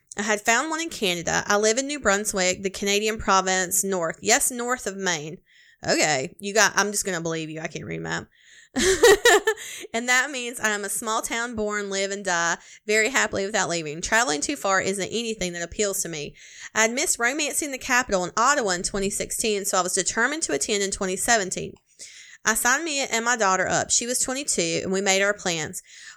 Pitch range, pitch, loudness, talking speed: 185-245 Hz, 205 Hz, -23 LUFS, 205 wpm